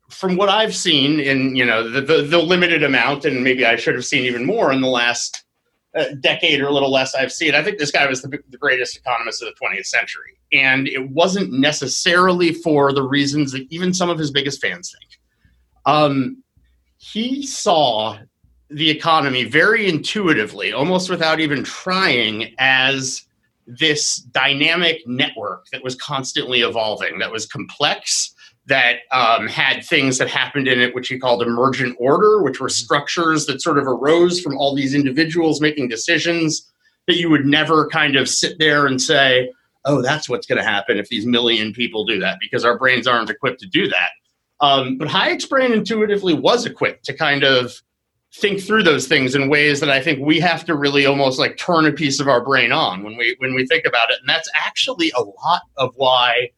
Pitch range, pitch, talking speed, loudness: 130-165 Hz, 140 Hz, 195 wpm, -17 LUFS